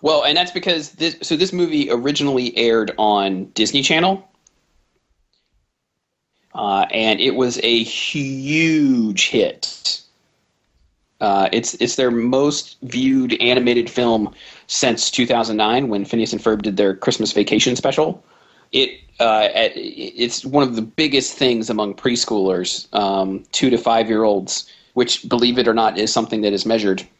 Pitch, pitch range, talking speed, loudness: 120 Hz, 110-145 Hz, 140 wpm, -18 LUFS